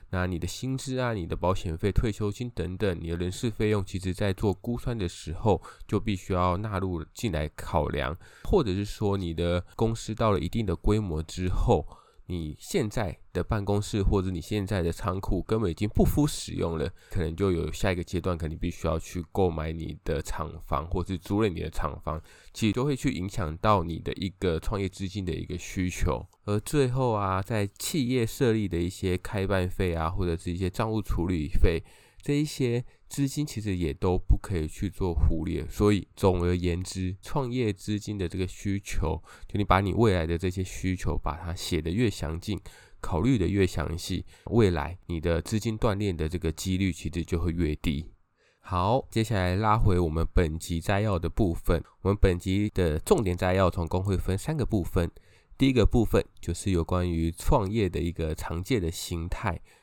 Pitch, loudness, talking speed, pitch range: 95 Hz, -29 LUFS, 285 characters per minute, 85-105 Hz